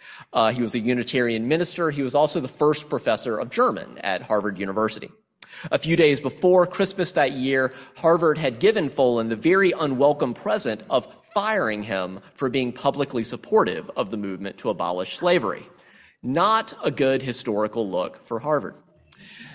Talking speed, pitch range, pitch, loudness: 160 wpm, 115-160 Hz, 130 Hz, -23 LUFS